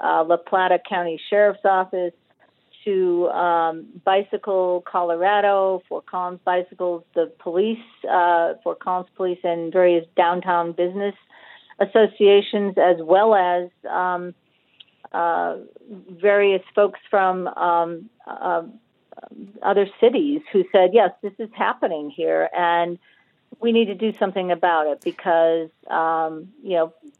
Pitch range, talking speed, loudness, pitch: 170-200 Hz, 120 wpm, -20 LUFS, 180 Hz